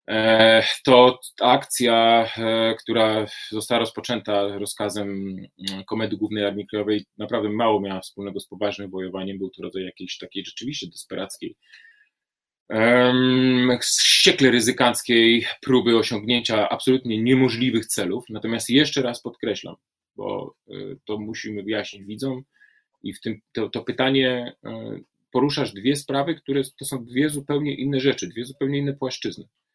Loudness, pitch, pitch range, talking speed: -21 LUFS, 115 Hz, 105-130 Hz, 125 wpm